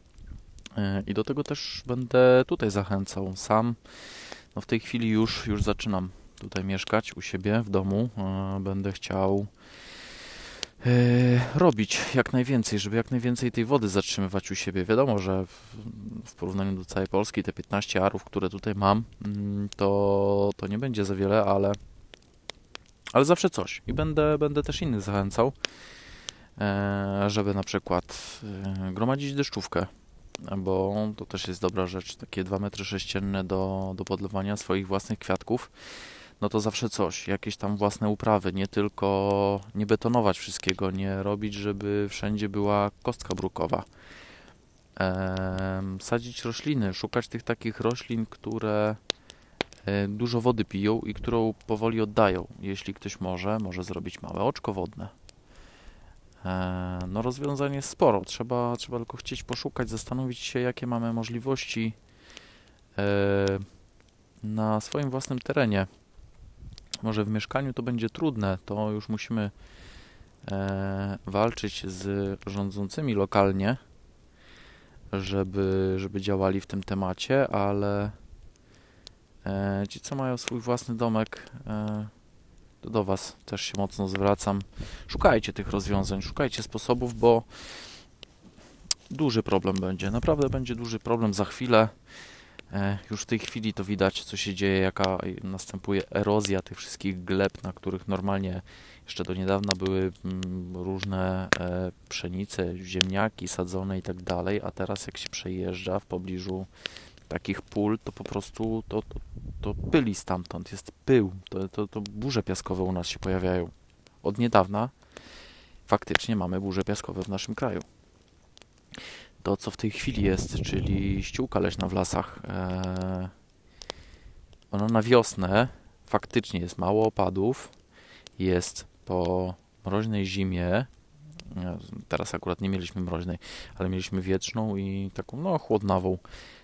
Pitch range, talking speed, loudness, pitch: 95-110 Hz, 130 wpm, -28 LUFS, 100 Hz